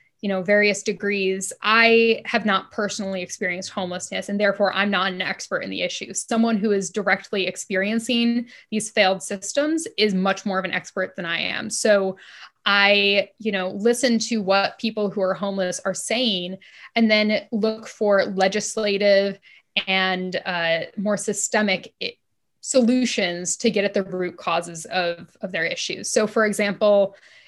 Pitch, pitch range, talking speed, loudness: 200 Hz, 190-220 Hz, 155 wpm, -22 LUFS